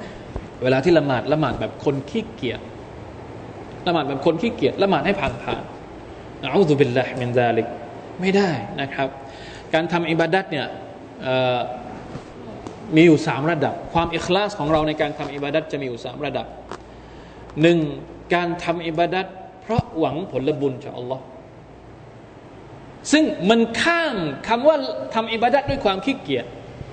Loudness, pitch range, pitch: -21 LUFS, 130-175 Hz, 150 Hz